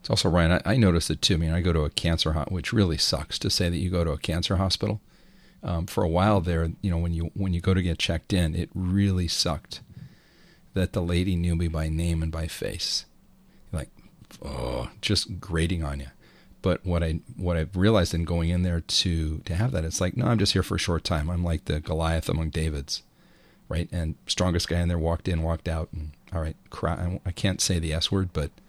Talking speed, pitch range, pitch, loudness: 240 wpm, 80-95 Hz, 85 Hz, -26 LUFS